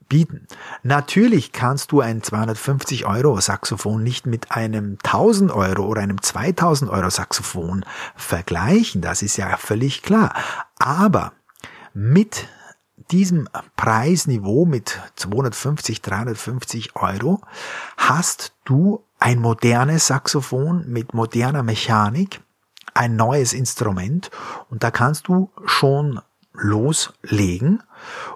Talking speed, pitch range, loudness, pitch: 105 wpm, 110-150 Hz, -19 LUFS, 125 Hz